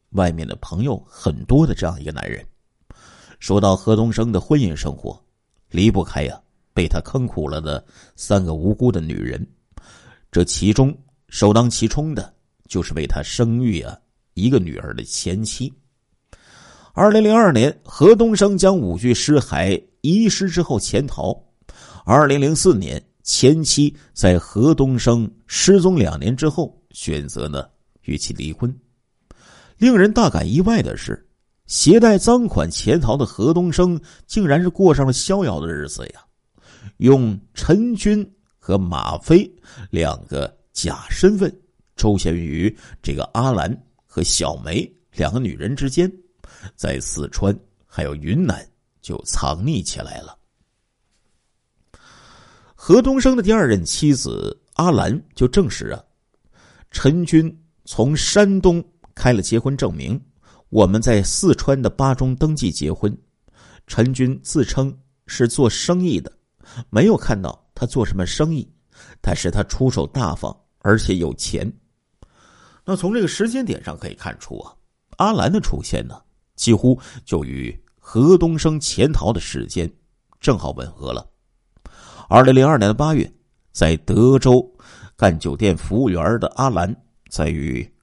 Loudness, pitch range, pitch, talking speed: -18 LUFS, 95-155 Hz, 125 Hz, 205 characters per minute